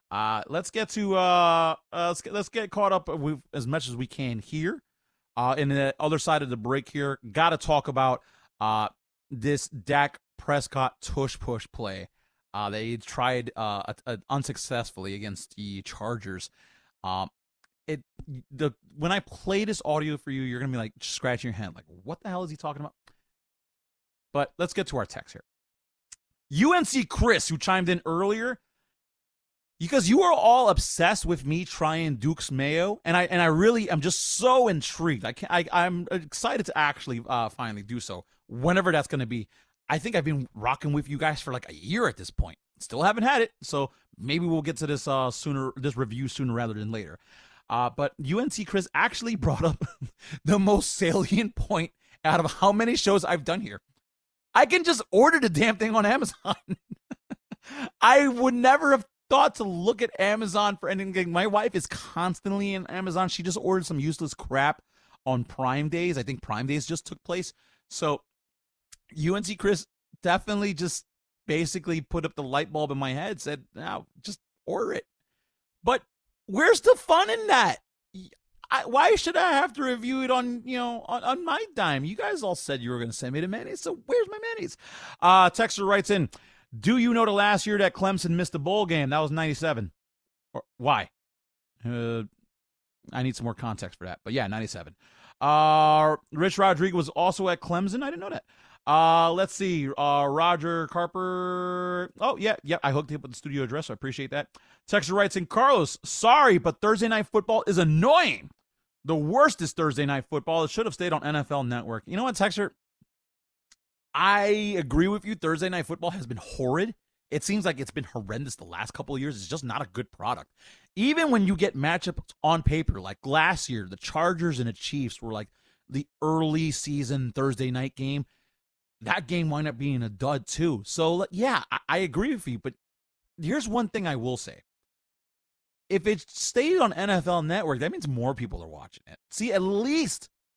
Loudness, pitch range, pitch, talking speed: -26 LUFS, 135-195 Hz, 160 Hz, 190 wpm